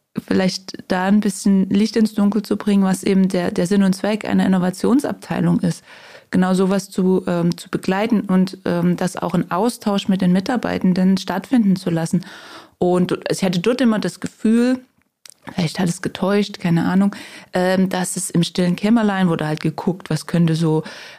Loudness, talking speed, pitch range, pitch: -19 LUFS, 175 wpm, 180-210 Hz, 190 Hz